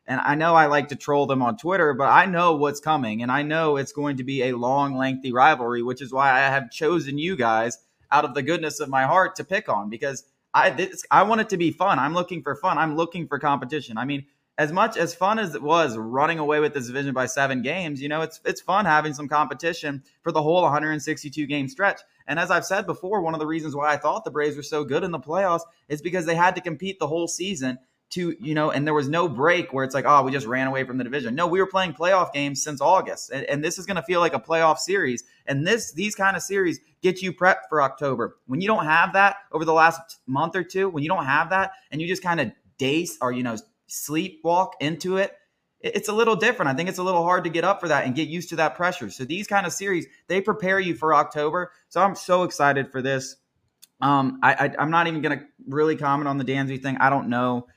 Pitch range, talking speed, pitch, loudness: 140-180 Hz, 260 wpm, 155 Hz, -23 LUFS